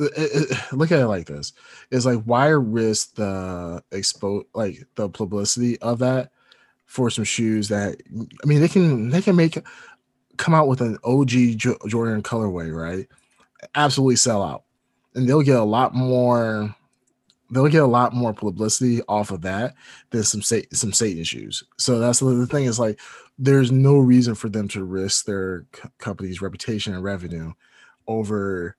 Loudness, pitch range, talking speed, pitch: -21 LUFS, 105-130 Hz, 165 wpm, 115 Hz